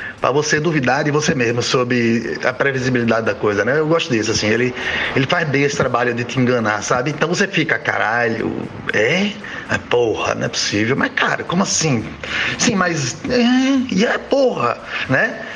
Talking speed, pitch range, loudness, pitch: 180 wpm, 120-185 Hz, -17 LUFS, 140 Hz